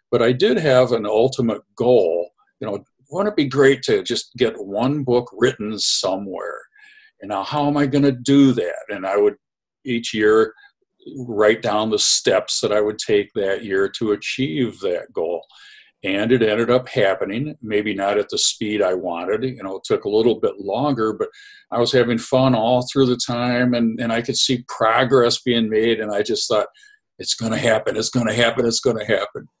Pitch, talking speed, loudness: 125 Hz, 205 wpm, -19 LUFS